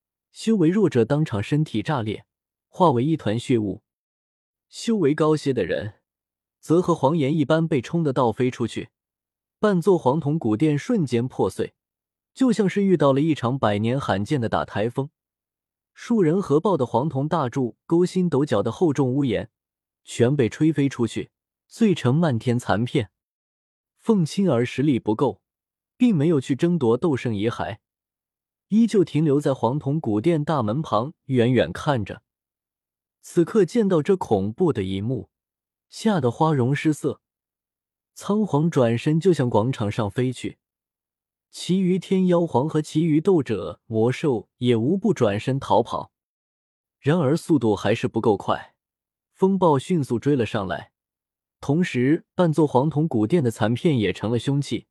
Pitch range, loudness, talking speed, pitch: 115-170 Hz, -22 LUFS, 220 characters per minute, 140 Hz